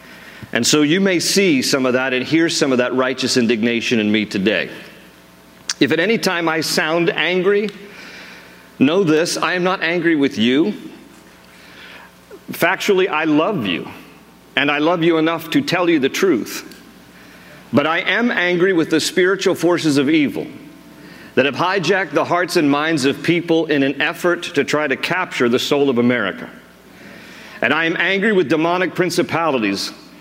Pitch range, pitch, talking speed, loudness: 135-180 Hz, 160 Hz, 165 wpm, -17 LUFS